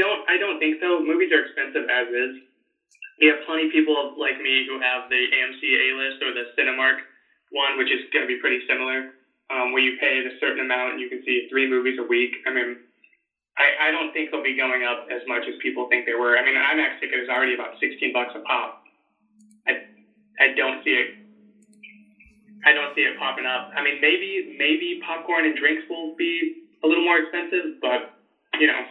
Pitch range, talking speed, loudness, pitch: 130-215 Hz, 215 wpm, -22 LUFS, 155 Hz